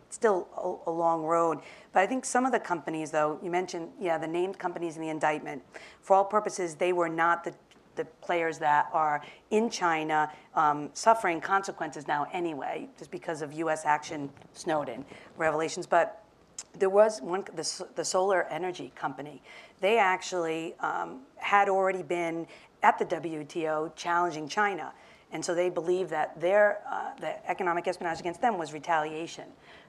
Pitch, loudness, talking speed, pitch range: 170 Hz, -29 LUFS, 160 wpm, 160-185 Hz